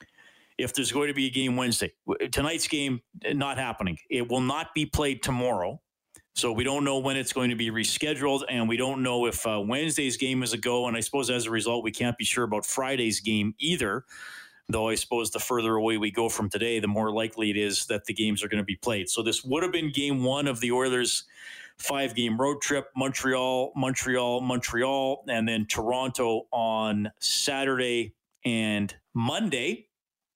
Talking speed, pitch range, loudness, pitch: 200 wpm, 110-135 Hz, -27 LUFS, 125 Hz